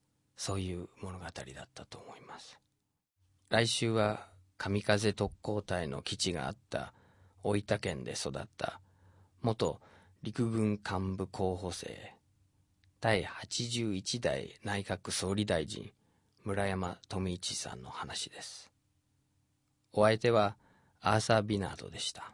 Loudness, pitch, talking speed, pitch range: -34 LUFS, 100 Hz, 205 characters per minute, 95-105 Hz